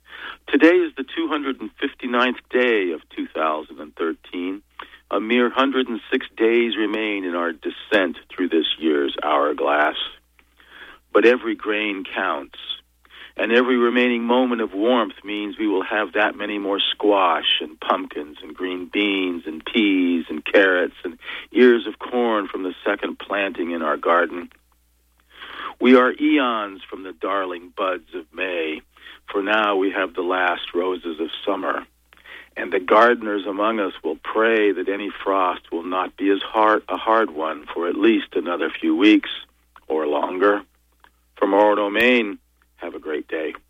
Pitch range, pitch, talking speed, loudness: 90-125 Hz, 105 Hz, 150 wpm, -21 LUFS